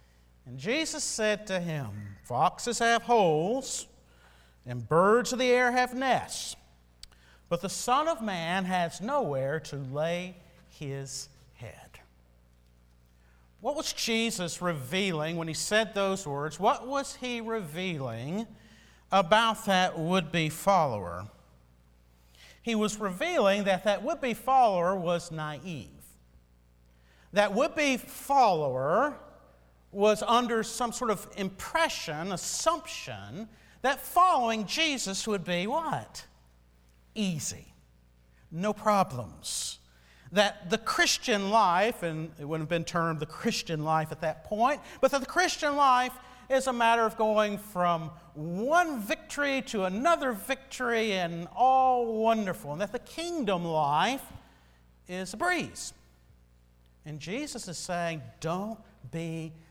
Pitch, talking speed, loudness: 185 Hz, 125 wpm, -29 LUFS